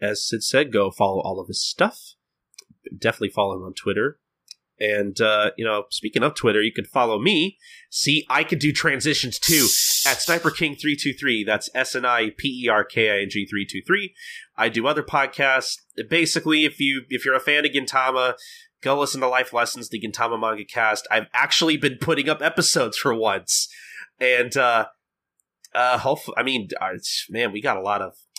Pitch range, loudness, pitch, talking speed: 110-155 Hz, -21 LUFS, 135 Hz, 200 wpm